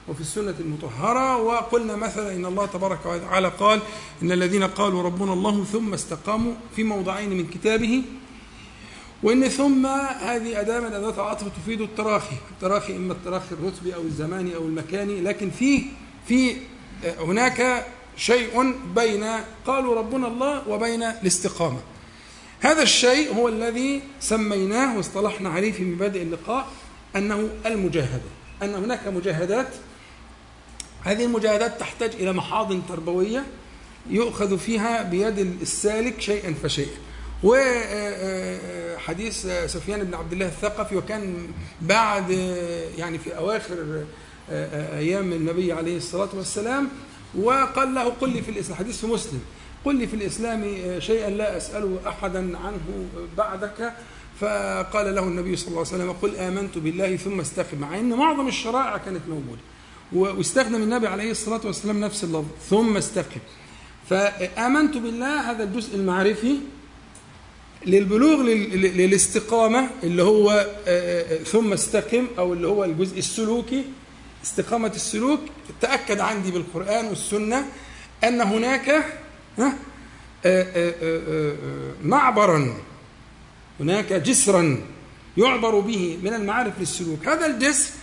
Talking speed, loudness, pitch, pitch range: 115 wpm, -23 LUFS, 205 Hz, 180-230 Hz